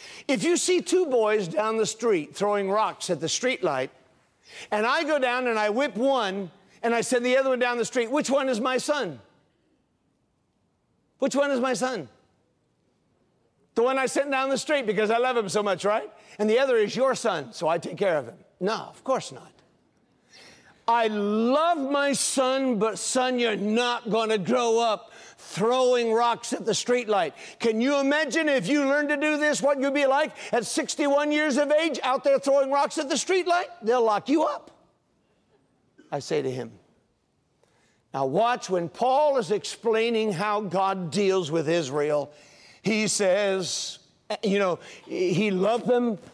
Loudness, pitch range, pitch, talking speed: -25 LUFS, 210-275 Hz, 240 Hz, 180 wpm